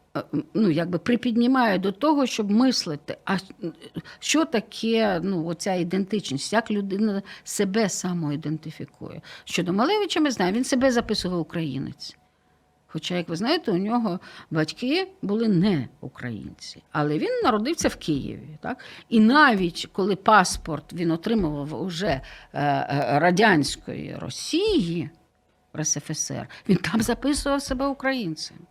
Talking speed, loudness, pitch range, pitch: 115 wpm, -24 LUFS, 160-235 Hz, 190 Hz